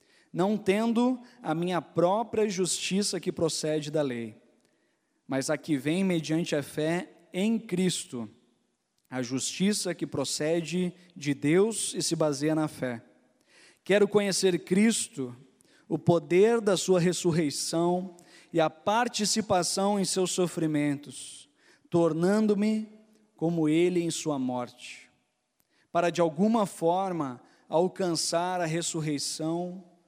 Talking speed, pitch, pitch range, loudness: 115 wpm, 170 Hz, 150-190 Hz, -28 LUFS